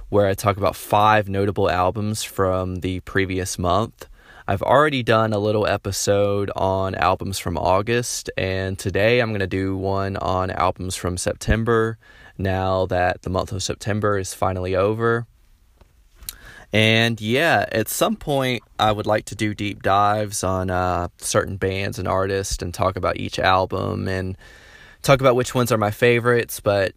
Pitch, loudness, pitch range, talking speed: 95 Hz, -21 LUFS, 95-105 Hz, 160 wpm